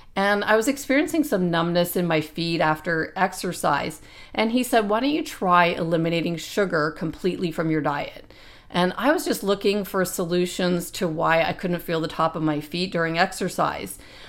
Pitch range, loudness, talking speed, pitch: 165-200 Hz, -23 LUFS, 180 wpm, 180 Hz